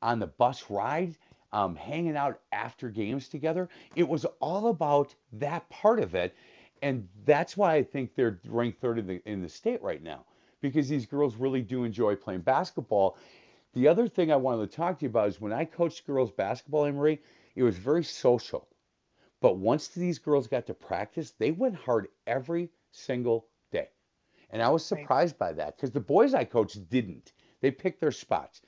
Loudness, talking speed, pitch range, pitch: -29 LUFS, 190 wpm, 125-165 Hz, 140 Hz